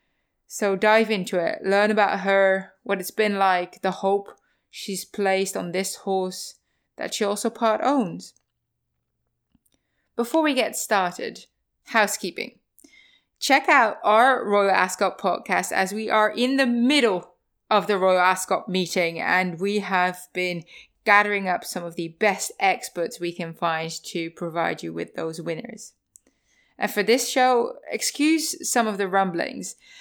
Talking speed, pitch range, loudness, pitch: 150 wpm, 180-220 Hz, -23 LUFS, 195 Hz